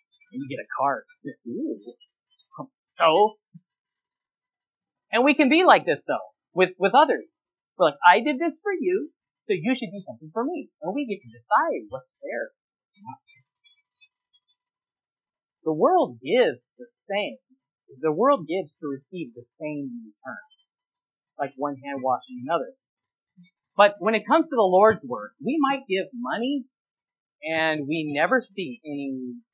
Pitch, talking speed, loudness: 220 Hz, 145 wpm, -24 LUFS